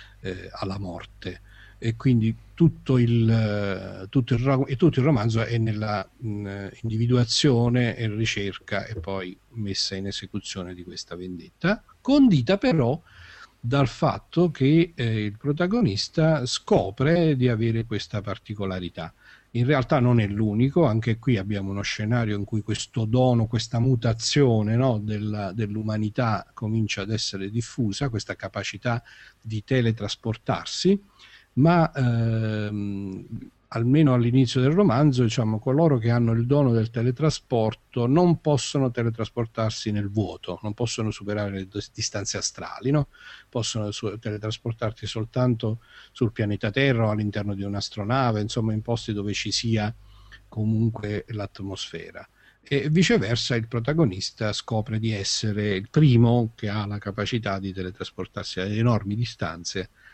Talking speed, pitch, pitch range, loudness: 130 wpm, 110 Hz, 105-125 Hz, -24 LUFS